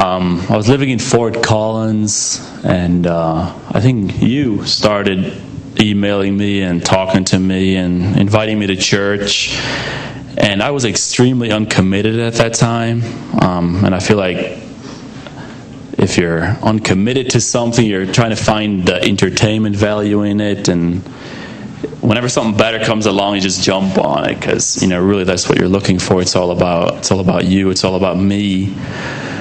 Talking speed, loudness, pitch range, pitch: 165 wpm, -14 LUFS, 95-115 Hz, 100 Hz